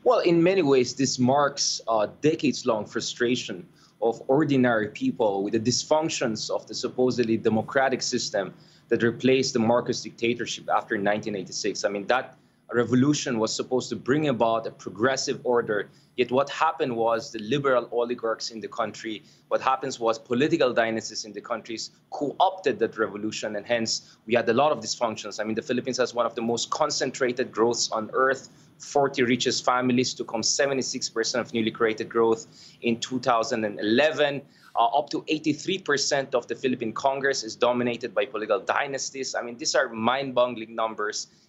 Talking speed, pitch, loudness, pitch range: 165 wpm, 120 Hz, -25 LUFS, 115-135 Hz